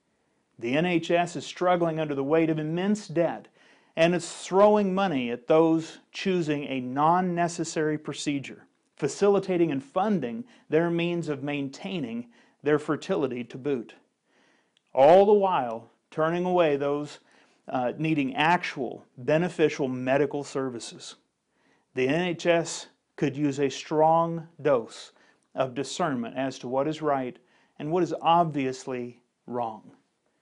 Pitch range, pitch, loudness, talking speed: 140-175 Hz, 155 Hz, -26 LUFS, 120 wpm